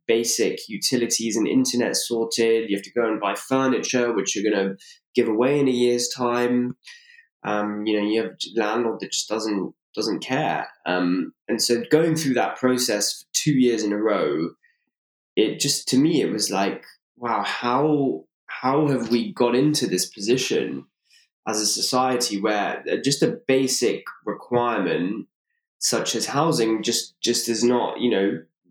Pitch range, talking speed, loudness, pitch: 110-135 Hz, 165 wpm, -22 LUFS, 120 Hz